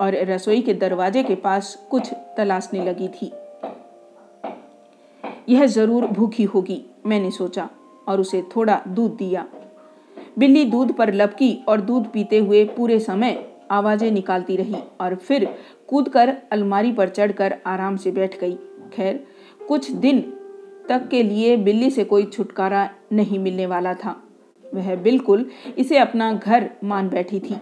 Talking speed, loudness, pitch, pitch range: 145 wpm, -20 LUFS, 210 Hz, 195-240 Hz